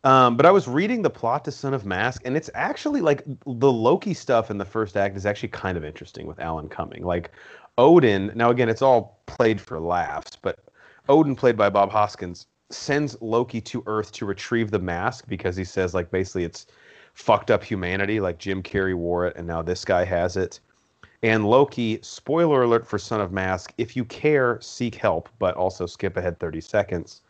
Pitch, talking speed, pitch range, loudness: 110 Hz, 200 wpm, 95-125 Hz, -23 LUFS